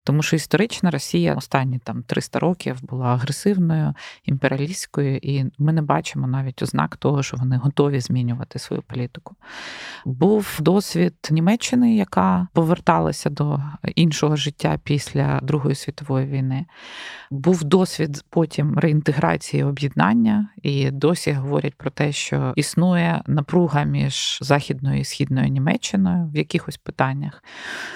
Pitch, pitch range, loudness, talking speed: 150 Hz, 135-170 Hz, -21 LUFS, 120 wpm